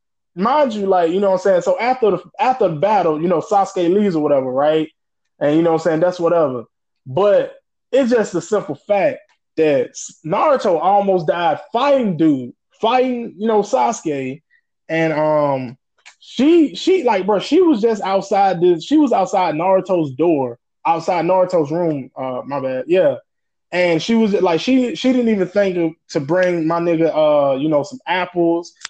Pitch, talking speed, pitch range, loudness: 180 Hz, 180 wpm, 160-220 Hz, -17 LUFS